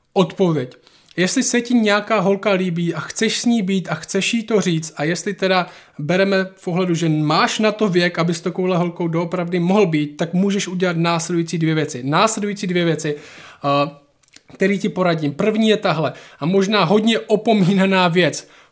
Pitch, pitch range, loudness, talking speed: 185 Hz, 165-205 Hz, -18 LUFS, 175 wpm